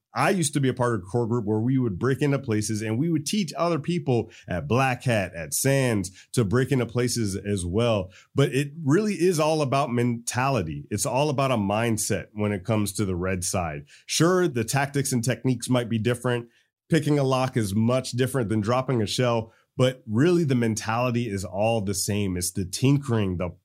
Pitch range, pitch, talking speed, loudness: 105-135 Hz, 120 Hz, 210 wpm, -25 LUFS